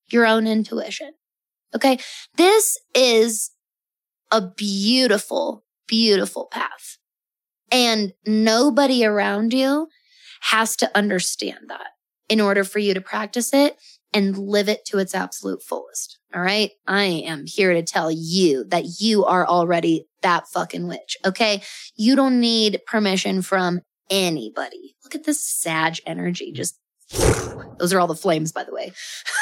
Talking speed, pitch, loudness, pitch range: 140 wpm, 210 Hz, -20 LUFS, 185-240 Hz